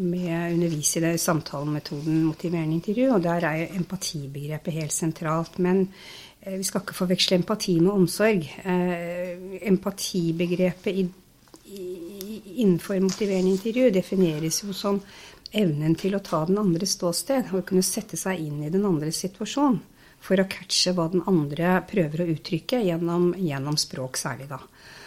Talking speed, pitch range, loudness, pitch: 135 wpm, 165-195 Hz, -25 LUFS, 180 Hz